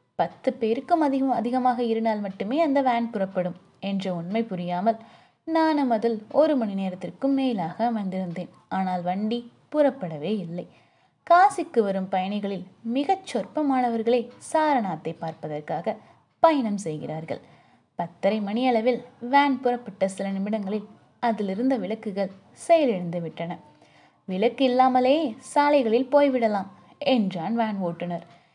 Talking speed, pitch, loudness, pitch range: 105 wpm, 225 Hz, -25 LUFS, 190-260 Hz